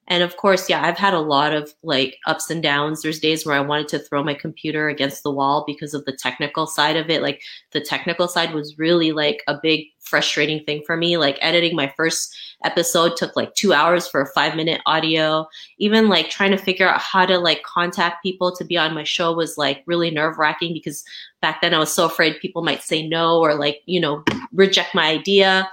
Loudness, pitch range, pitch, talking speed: -19 LUFS, 150-175 Hz, 160 Hz, 230 wpm